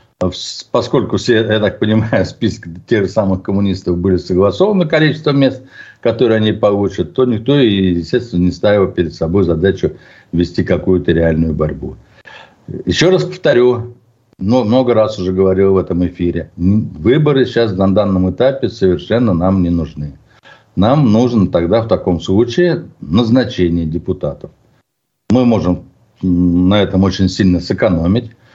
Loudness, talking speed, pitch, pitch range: -14 LUFS, 130 wpm, 95 Hz, 90-120 Hz